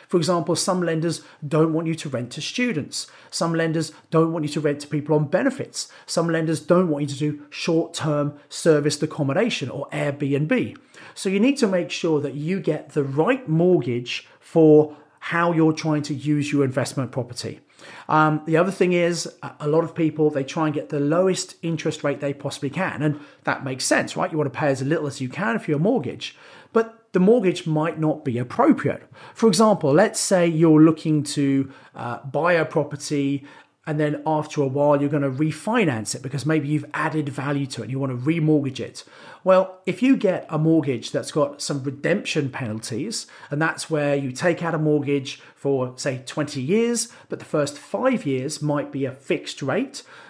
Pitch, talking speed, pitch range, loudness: 155 Hz, 200 wpm, 145-170 Hz, -22 LUFS